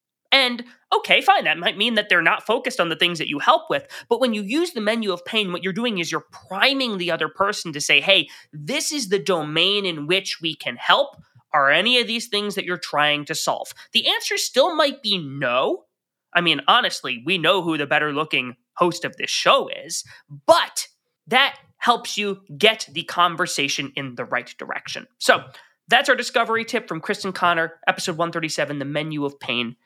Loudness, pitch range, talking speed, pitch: -20 LUFS, 155-230 Hz, 205 wpm, 185 Hz